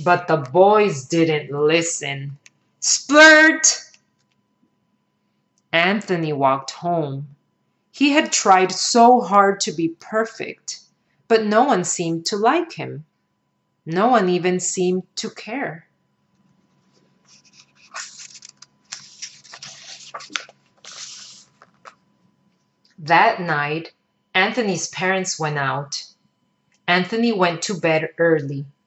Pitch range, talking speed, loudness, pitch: 160-215 Hz, 85 wpm, -18 LUFS, 180 Hz